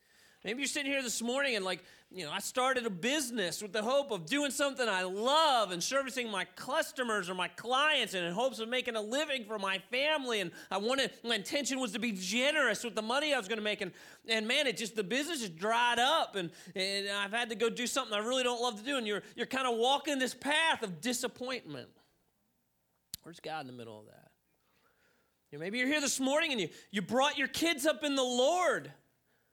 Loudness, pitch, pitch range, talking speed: -32 LUFS, 240 Hz, 200-270 Hz, 230 wpm